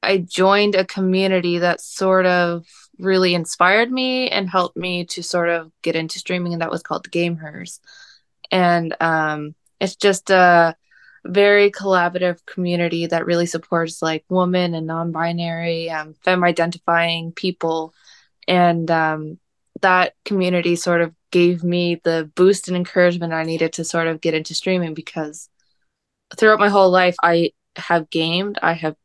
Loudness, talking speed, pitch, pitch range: -18 LUFS, 150 wpm, 175 Hz, 165-185 Hz